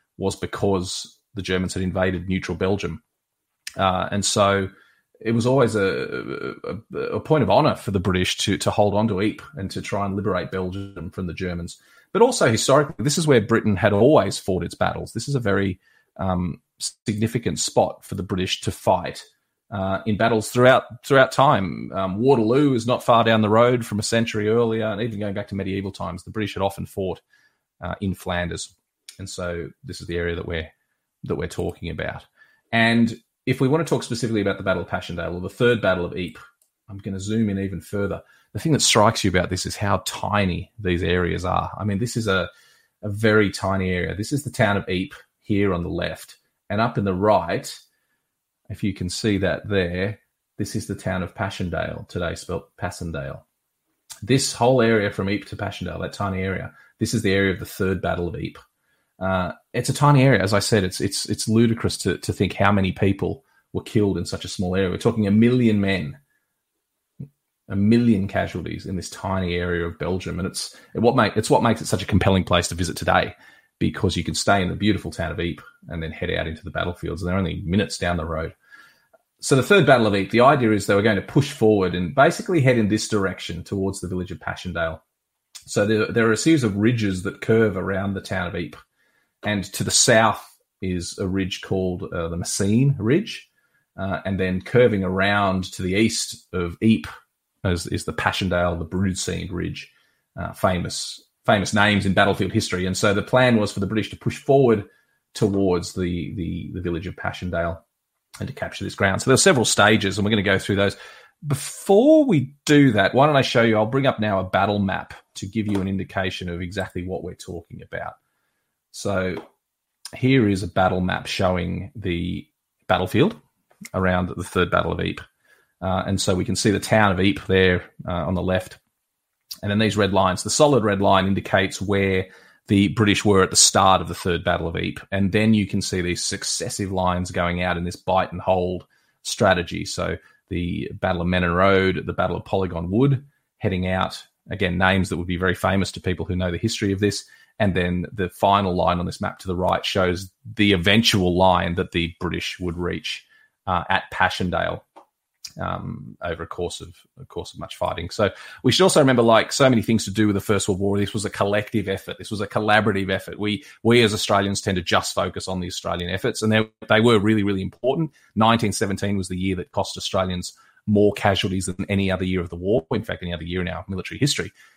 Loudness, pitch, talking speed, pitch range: -21 LUFS, 95 Hz, 215 wpm, 90-110 Hz